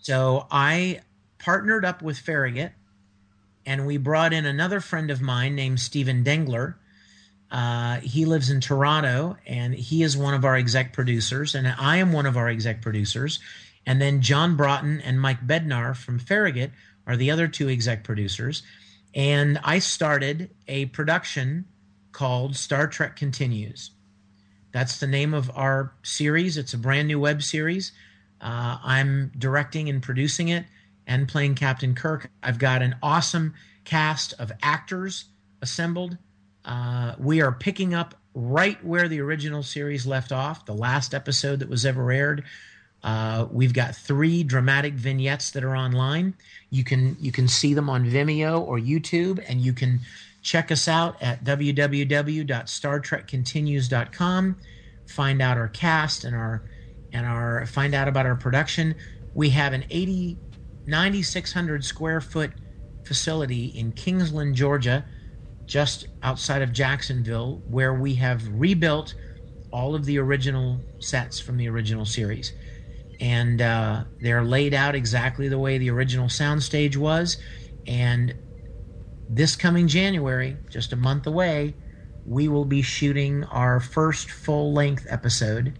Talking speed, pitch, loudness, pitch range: 145 wpm, 135 Hz, -24 LUFS, 120-150 Hz